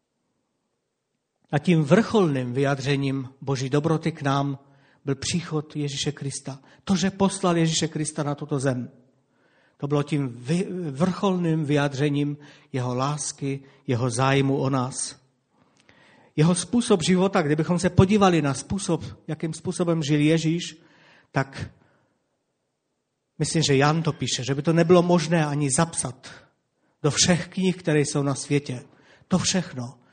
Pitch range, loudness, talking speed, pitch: 135-170 Hz, -24 LUFS, 130 wpm, 150 Hz